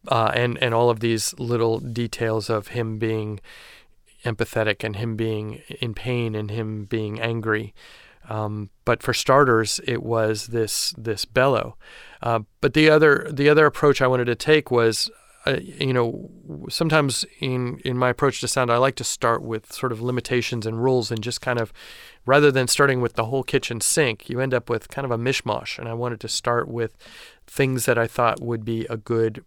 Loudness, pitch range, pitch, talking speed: -22 LUFS, 115-130 Hz, 120 Hz, 195 wpm